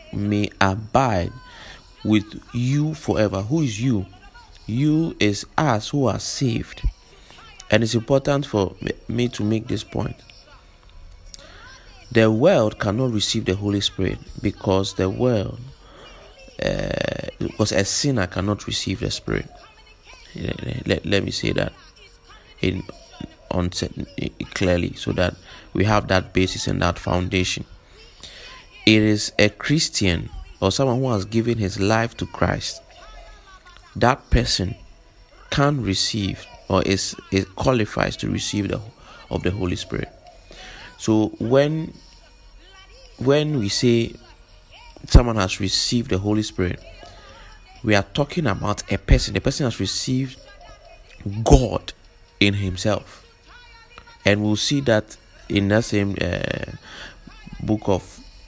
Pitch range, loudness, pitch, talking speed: 95-125 Hz, -22 LUFS, 105 Hz, 125 wpm